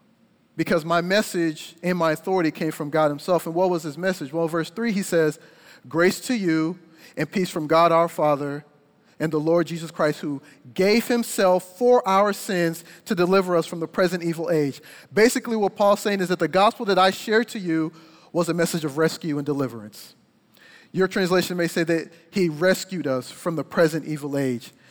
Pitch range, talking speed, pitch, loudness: 160-190 Hz, 195 wpm, 170 Hz, -23 LUFS